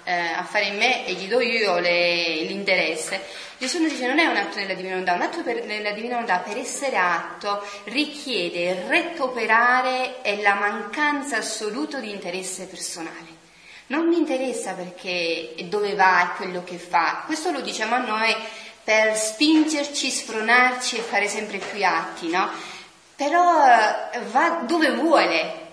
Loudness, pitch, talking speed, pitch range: -22 LUFS, 215 Hz, 150 wpm, 185-255 Hz